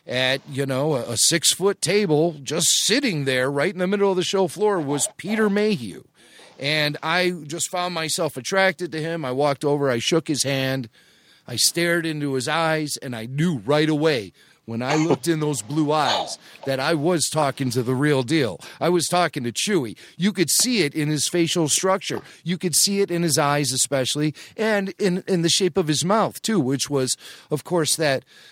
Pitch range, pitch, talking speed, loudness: 140-180 Hz, 160 Hz, 200 wpm, -21 LUFS